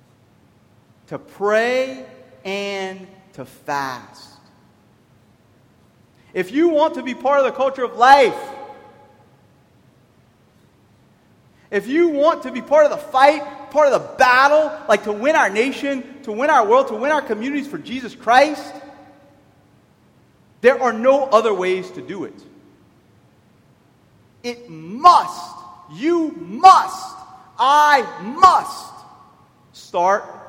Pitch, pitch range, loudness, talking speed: 255 Hz, 190-295 Hz, -16 LUFS, 120 wpm